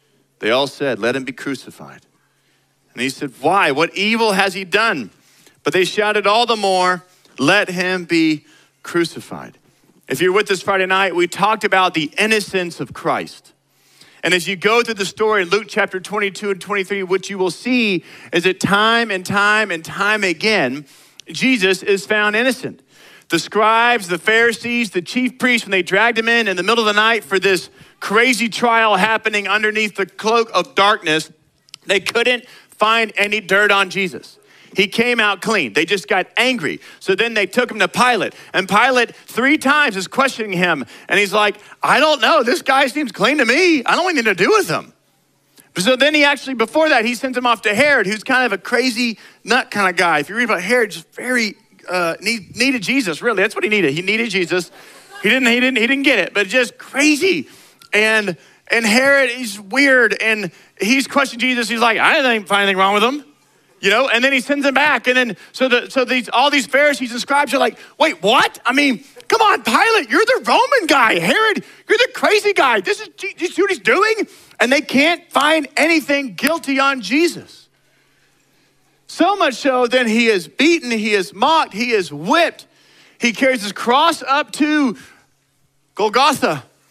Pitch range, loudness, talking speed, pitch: 195-265 Hz, -16 LUFS, 195 wpm, 225 Hz